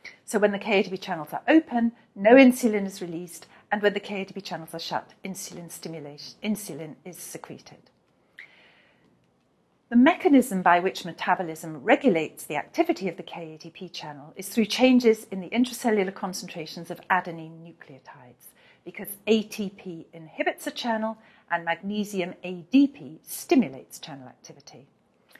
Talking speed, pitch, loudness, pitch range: 130 wpm, 190 Hz, -25 LUFS, 170-220 Hz